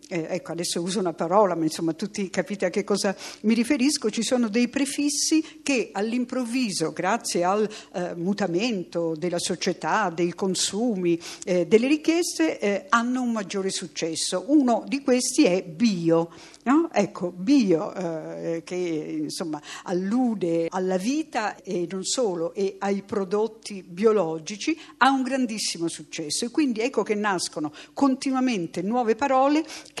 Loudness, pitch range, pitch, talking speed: -25 LUFS, 175-250 Hz, 200 Hz, 140 wpm